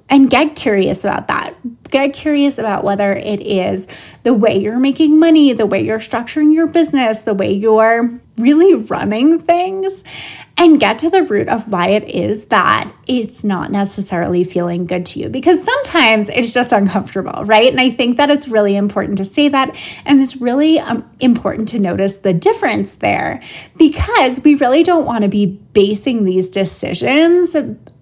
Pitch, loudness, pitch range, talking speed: 240 Hz, -13 LUFS, 205-300 Hz, 170 wpm